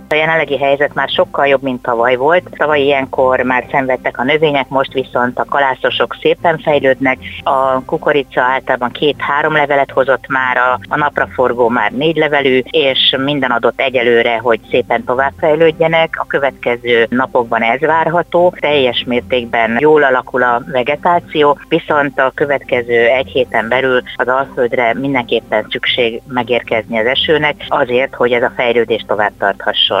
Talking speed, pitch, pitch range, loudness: 145 wpm, 135 Hz, 125-155 Hz, -13 LUFS